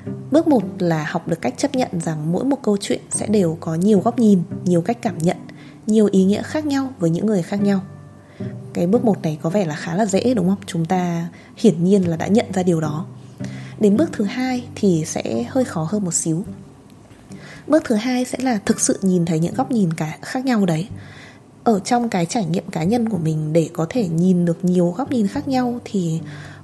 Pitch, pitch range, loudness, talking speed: 185 Hz, 165-230 Hz, -19 LUFS, 230 wpm